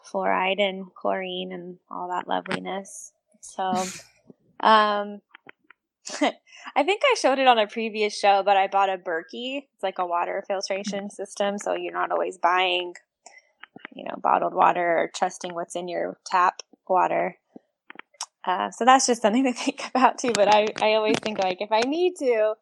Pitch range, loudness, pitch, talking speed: 185-230 Hz, -24 LUFS, 205 Hz, 170 wpm